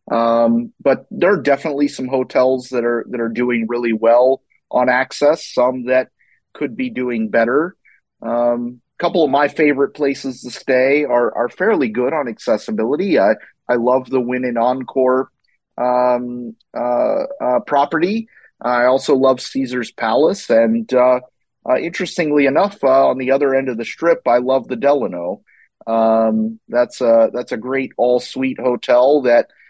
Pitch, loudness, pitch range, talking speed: 125 Hz, -17 LUFS, 120-140 Hz, 160 wpm